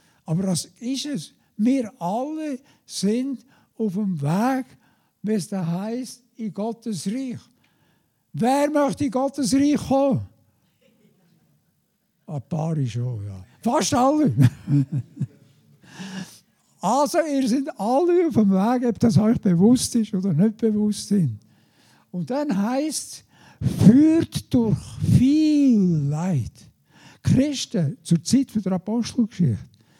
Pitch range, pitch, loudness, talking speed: 170-260 Hz, 215 Hz, -22 LUFS, 115 wpm